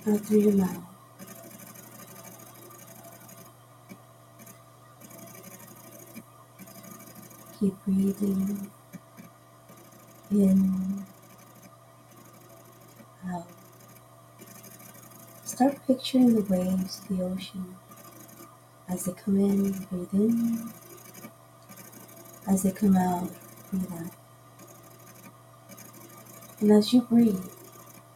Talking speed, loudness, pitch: 65 wpm, -26 LUFS, 190 Hz